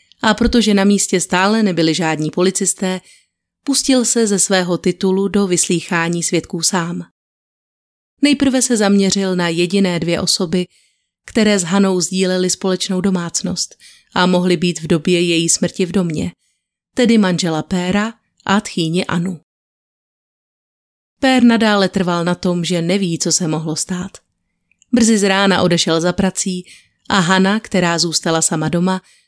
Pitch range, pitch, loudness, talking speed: 175-200 Hz, 185 Hz, -15 LUFS, 140 wpm